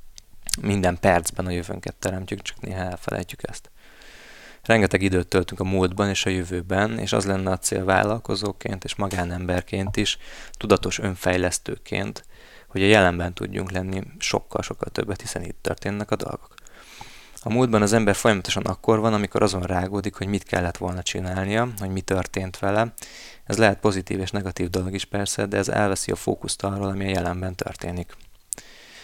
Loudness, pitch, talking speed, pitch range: -24 LUFS, 95 Hz, 160 wpm, 90-105 Hz